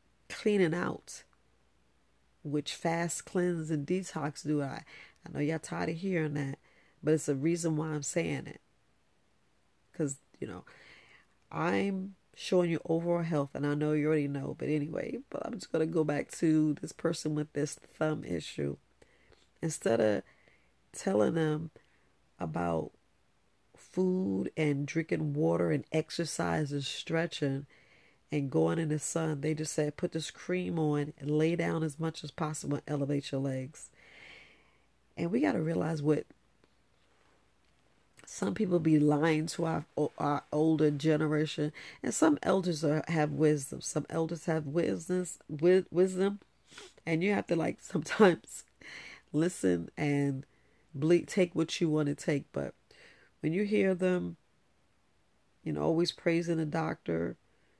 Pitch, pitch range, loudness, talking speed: 155 Hz, 145-165 Hz, -32 LUFS, 145 wpm